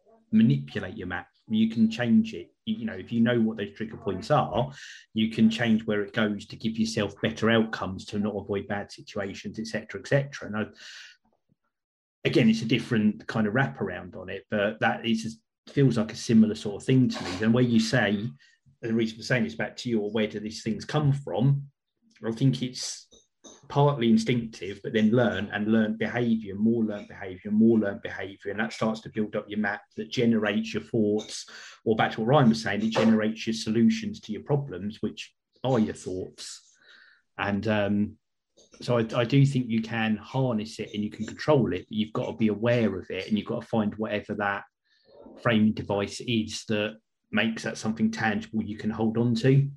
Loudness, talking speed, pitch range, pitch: -27 LUFS, 200 wpm, 105-125 Hz, 110 Hz